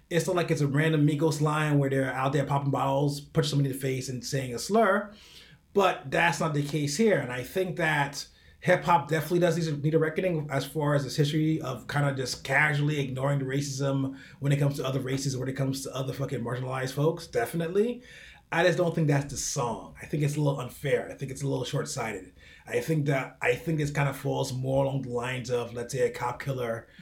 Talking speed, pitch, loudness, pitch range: 240 wpm, 145 Hz, -28 LUFS, 135-160 Hz